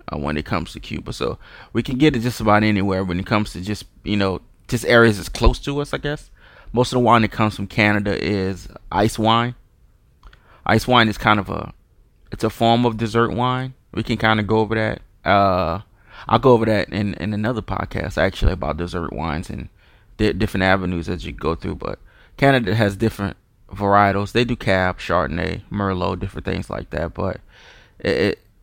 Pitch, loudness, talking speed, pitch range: 105 Hz, -20 LUFS, 205 wpm, 95-115 Hz